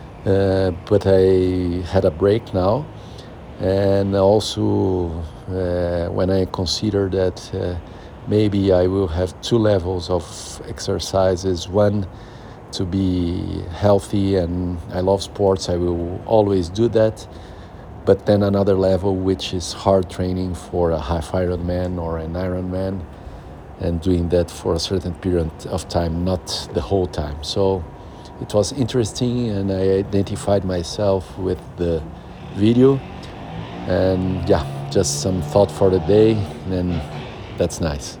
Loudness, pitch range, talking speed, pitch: -20 LUFS, 90-100 Hz, 140 wpm, 95 Hz